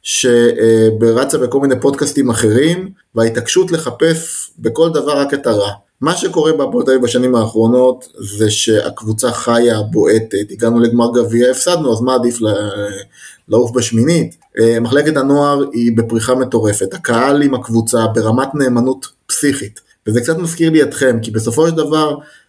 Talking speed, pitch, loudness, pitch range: 140 wpm, 120 Hz, -13 LUFS, 115-140 Hz